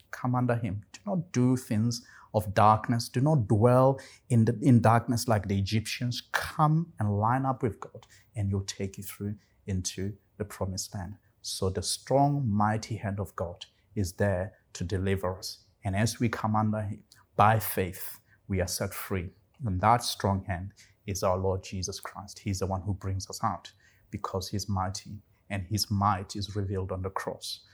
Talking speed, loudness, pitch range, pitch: 185 wpm, -29 LUFS, 95-115 Hz, 105 Hz